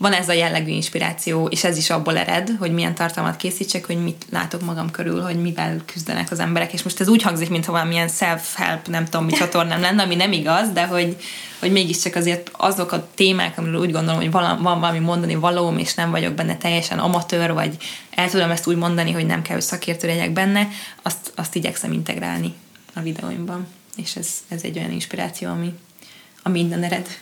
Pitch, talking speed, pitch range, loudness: 175 Hz, 200 wpm, 165-180 Hz, -21 LUFS